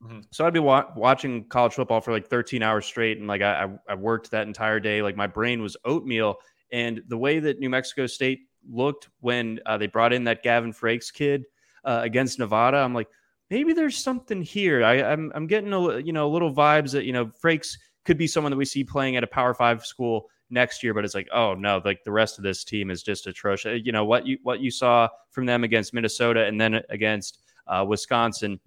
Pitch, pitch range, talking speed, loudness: 120 Hz, 110-135 Hz, 225 wpm, -24 LUFS